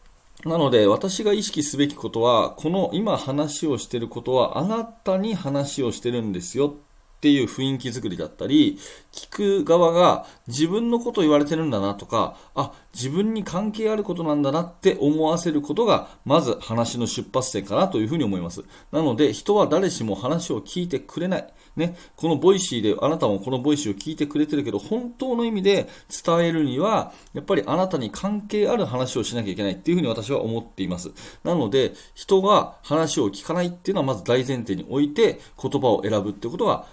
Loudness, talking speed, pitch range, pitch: -23 LUFS, 400 characters per minute, 125-185 Hz, 150 Hz